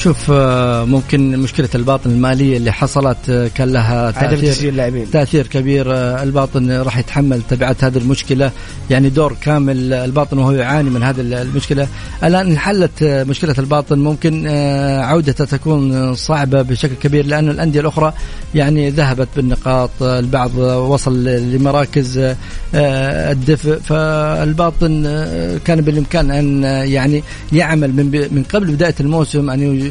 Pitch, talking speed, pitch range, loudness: 140 Hz, 120 wpm, 130-150 Hz, -14 LUFS